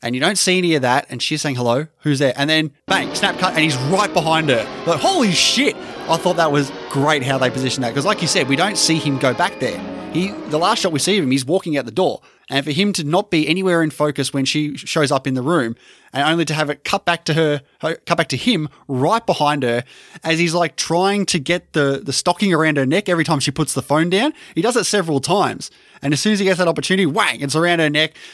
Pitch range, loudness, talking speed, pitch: 140-175 Hz, -18 LUFS, 275 wpm, 155 Hz